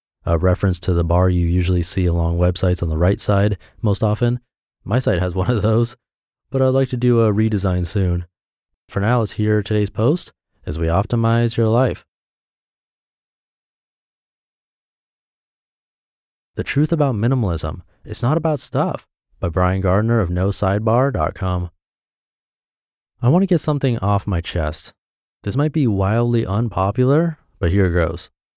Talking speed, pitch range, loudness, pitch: 150 wpm, 90-120 Hz, -19 LUFS, 100 Hz